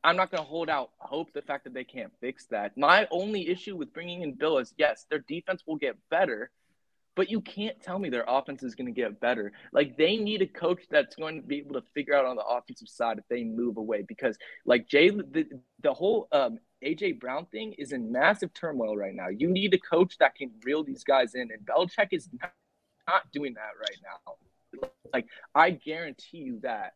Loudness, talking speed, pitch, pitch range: -29 LUFS, 225 wpm, 170 Hz, 140-210 Hz